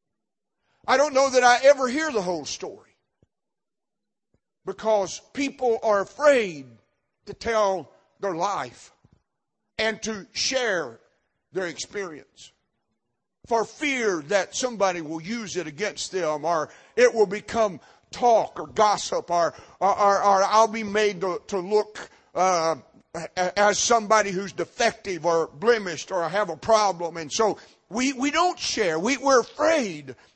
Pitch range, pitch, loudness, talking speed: 180-240 Hz, 210 Hz, -23 LUFS, 135 wpm